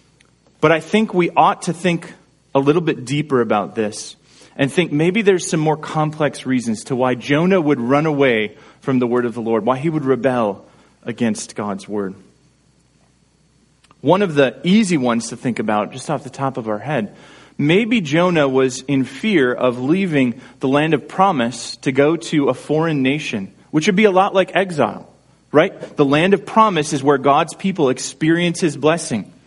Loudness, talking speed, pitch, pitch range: -17 LUFS, 185 wpm, 145 Hz, 130-175 Hz